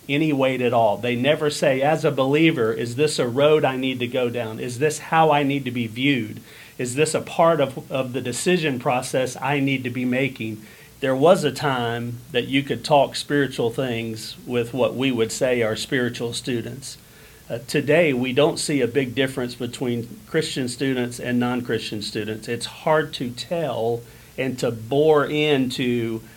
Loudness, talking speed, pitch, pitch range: -22 LUFS, 185 wpm, 130 Hz, 120-145 Hz